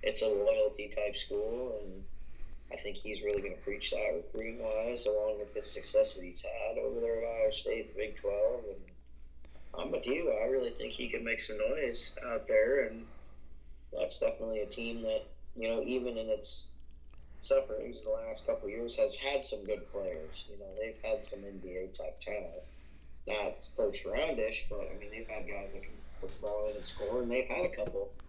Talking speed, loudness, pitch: 200 wpm, -36 LUFS, 140 Hz